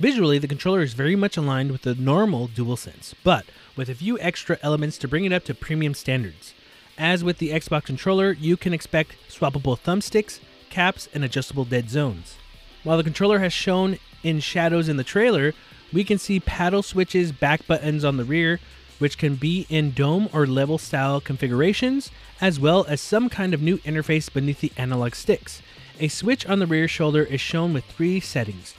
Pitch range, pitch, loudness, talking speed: 140-180 Hz, 155 Hz, -23 LUFS, 190 wpm